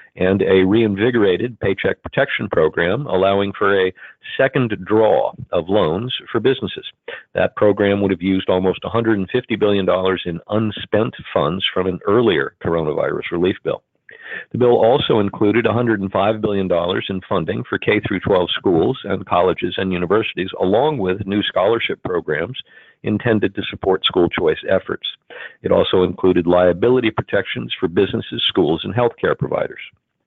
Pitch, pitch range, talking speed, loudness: 100 Hz, 95-110 Hz, 135 wpm, -18 LUFS